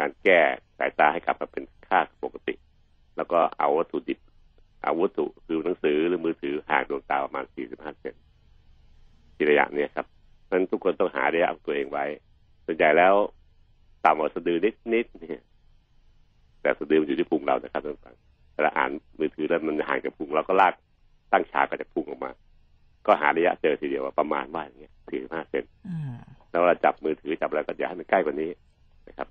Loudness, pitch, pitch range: -26 LUFS, 380 Hz, 350-430 Hz